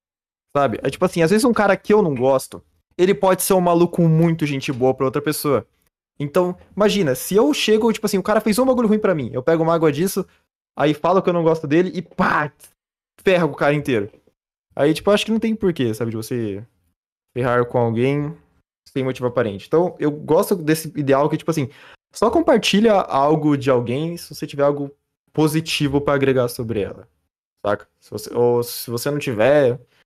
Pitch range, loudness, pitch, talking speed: 135-185 Hz, -19 LUFS, 150 Hz, 205 wpm